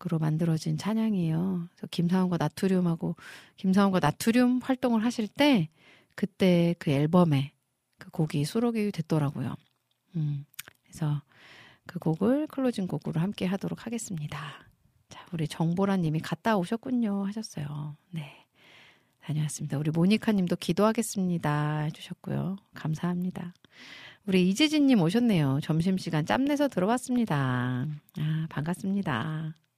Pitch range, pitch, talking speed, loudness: 155-205 Hz, 175 Hz, 310 characters per minute, -28 LUFS